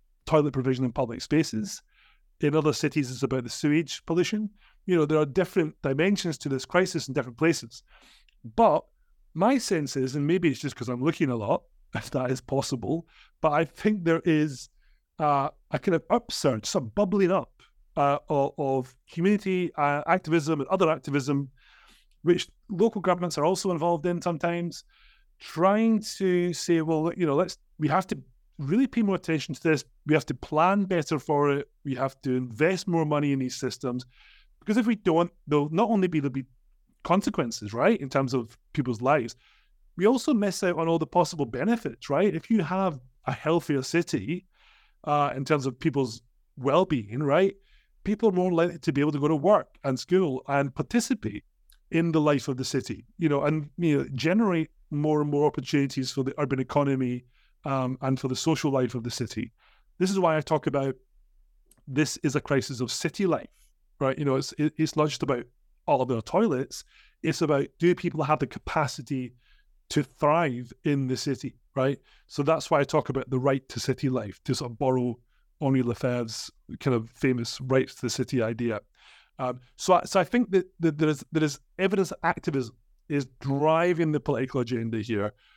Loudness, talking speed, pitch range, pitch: -27 LUFS, 190 wpm, 130-170 Hz, 150 Hz